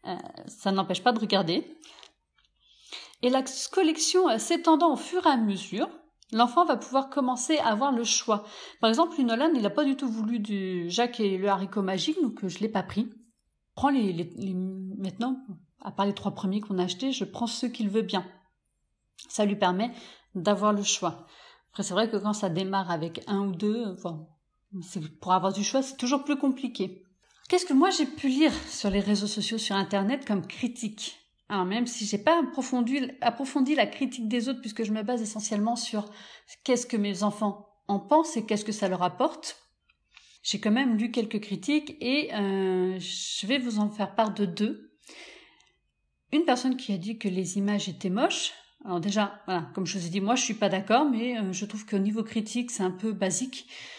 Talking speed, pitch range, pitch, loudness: 205 wpm, 195-260 Hz, 215 Hz, -28 LUFS